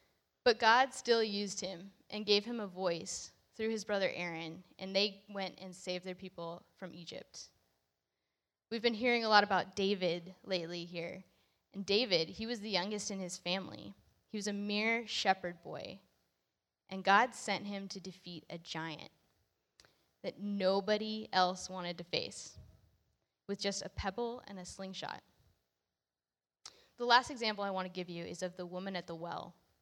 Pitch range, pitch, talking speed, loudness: 170-205 Hz, 190 Hz, 165 wpm, -35 LUFS